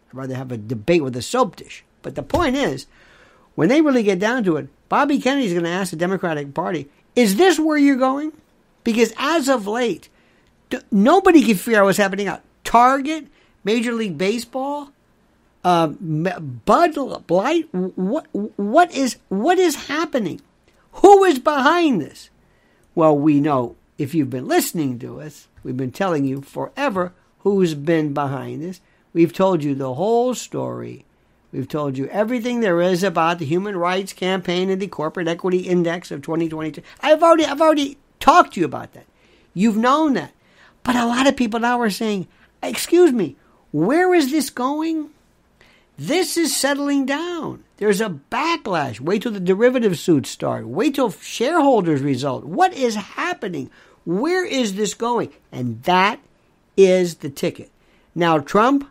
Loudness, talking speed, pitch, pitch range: -19 LUFS, 165 wpm, 210 Hz, 170-280 Hz